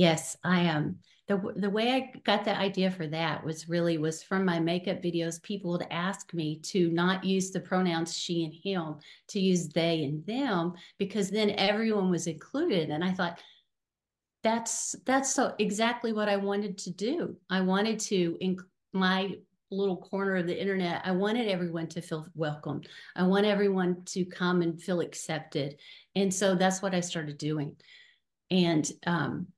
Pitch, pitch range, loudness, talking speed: 180 Hz, 170-200 Hz, -30 LUFS, 175 wpm